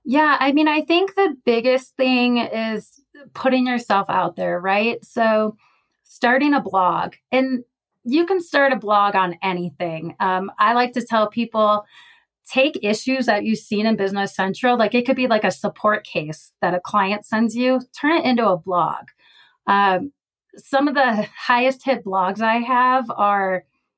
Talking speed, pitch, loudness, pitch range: 170 wpm, 230 Hz, -19 LUFS, 200-260 Hz